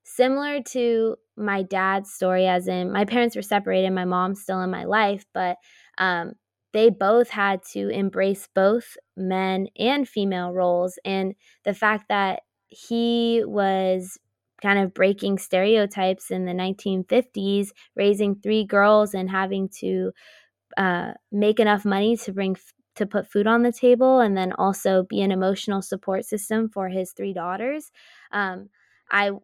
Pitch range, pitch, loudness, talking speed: 190-215 Hz, 200 Hz, -23 LUFS, 155 wpm